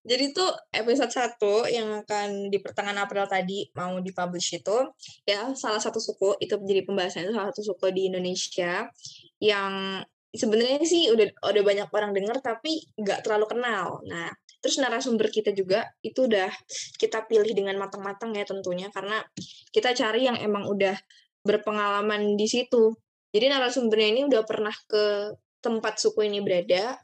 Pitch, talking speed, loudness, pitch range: 210 Hz, 155 wpm, -26 LUFS, 195-230 Hz